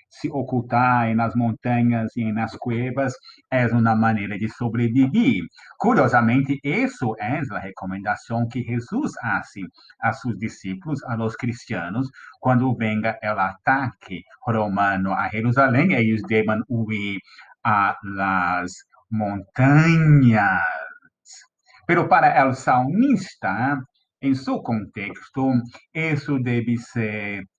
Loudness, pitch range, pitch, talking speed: -21 LUFS, 110-130 Hz, 120 Hz, 105 wpm